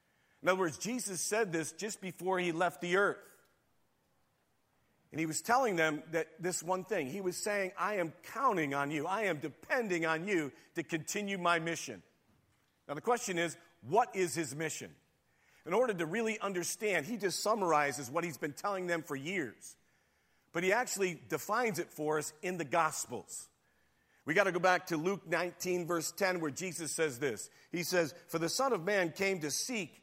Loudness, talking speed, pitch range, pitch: -34 LUFS, 190 wpm, 160-195 Hz, 175 Hz